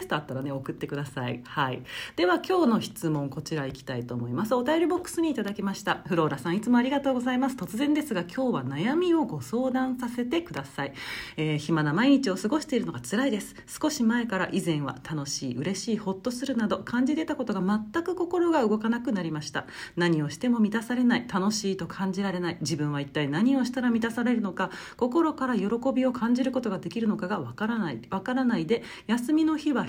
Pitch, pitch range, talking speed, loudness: 215 Hz, 160-255 Hz, 445 characters per minute, -28 LUFS